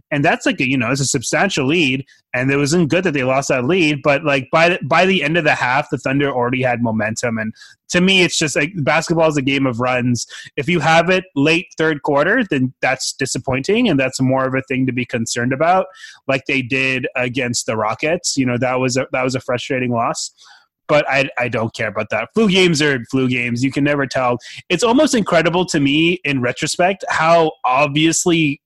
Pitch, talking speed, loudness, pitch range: 140 Hz, 225 wpm, -16 LUFS, 130-160 Hz